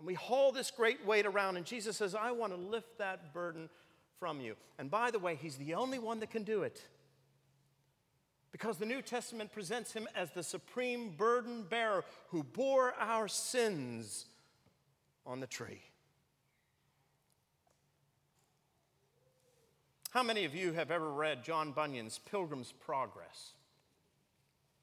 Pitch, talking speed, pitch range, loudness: 185 Hz, 145 wpm, 150-225 Hz, -38 LUFS